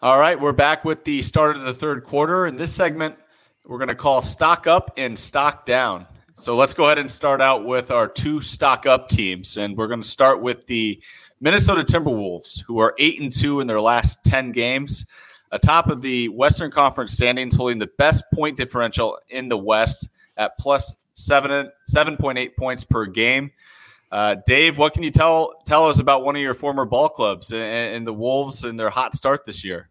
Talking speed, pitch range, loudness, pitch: 205 wpm, 115-145 Hz, -19 LUFS, 130 Hz